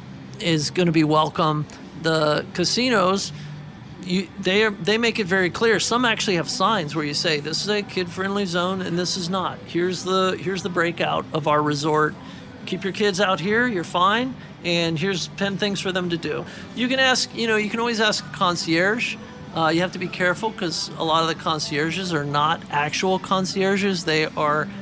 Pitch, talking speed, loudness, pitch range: 180 Hz, 195 wpm, -22 LUFS, 160-200 Hz